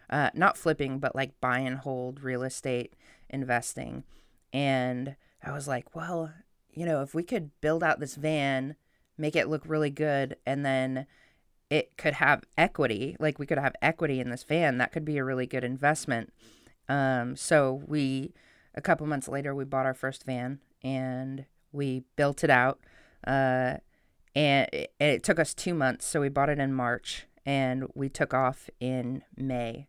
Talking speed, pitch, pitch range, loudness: 175 wpm, 135 Hz, 130-150 Hz, -29 LUFS